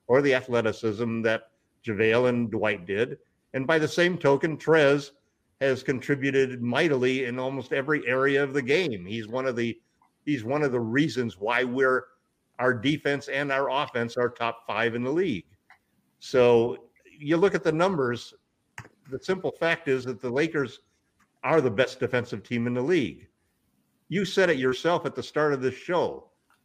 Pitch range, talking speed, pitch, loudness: 120-145 Hz, 175 wpm, 130 Hz, -26 LUFS